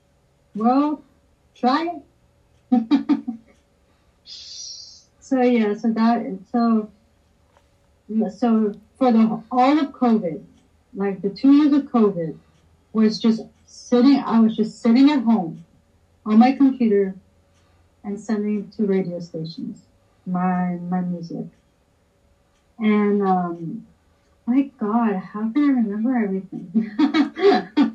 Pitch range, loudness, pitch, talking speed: 175-245 Hz, -20 LUFS, 215 Hz, 105 wpm